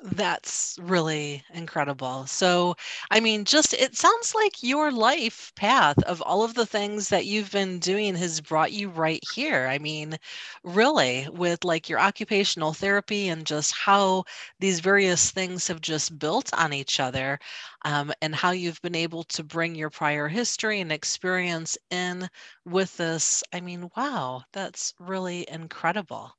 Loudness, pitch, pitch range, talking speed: -25 LUFS, 175 Hz, 155-200 Hz, 155 wpm